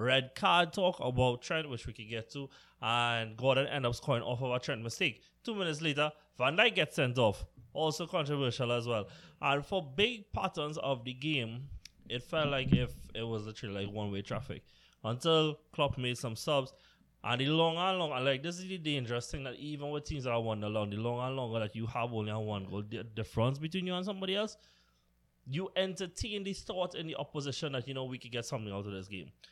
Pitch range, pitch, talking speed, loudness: 115-155 Hz, 130 Hz, 225 wpm, -34 LUFS